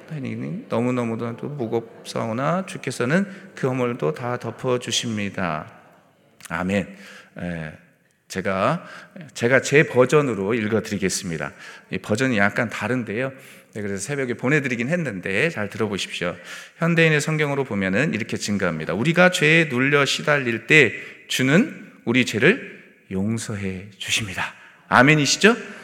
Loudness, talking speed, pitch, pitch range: -21 LUFS, 285 characters per minute, 125 Hz, 110-150 Hz